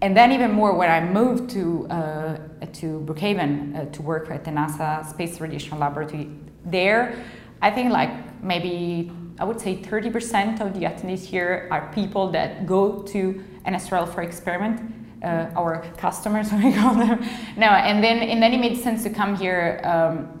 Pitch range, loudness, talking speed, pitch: 165-215 Hz, -22 LUFS, 175 wpm, 185 Hz